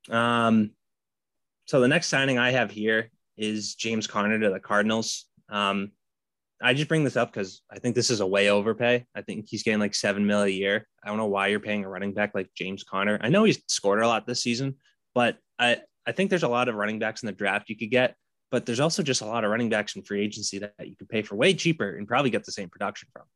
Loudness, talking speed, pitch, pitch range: -26 LUFS, 255 wpm, 110 Hz, 100-125 Hz